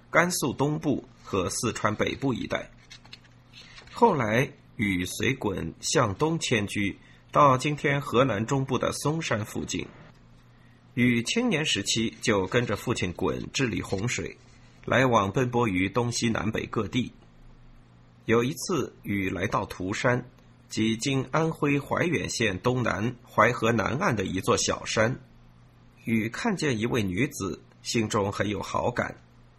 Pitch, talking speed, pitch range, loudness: 120 Hz, 195 characters per minute, 100-135 Hz, -27 LUFS